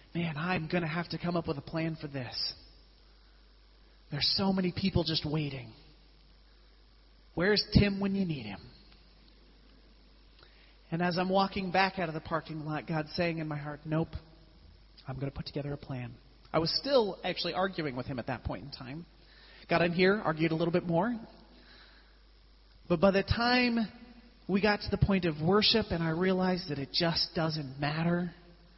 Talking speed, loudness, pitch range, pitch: 175 wpm, -31 LUFS, 145-185 Hz, 165 Hz